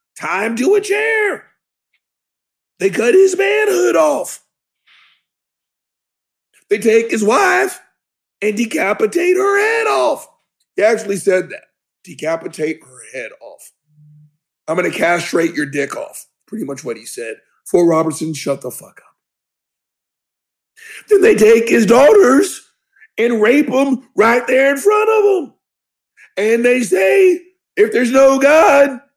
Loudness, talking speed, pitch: -14 LUFS, 135 wpm, 245 Hz